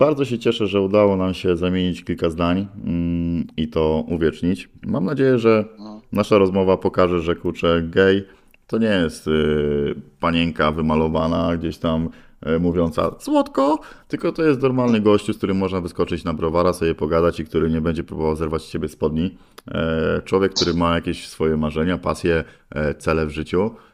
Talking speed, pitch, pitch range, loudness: 160 wpm, 85 Hz, 80-100 Hz, -20 LUFS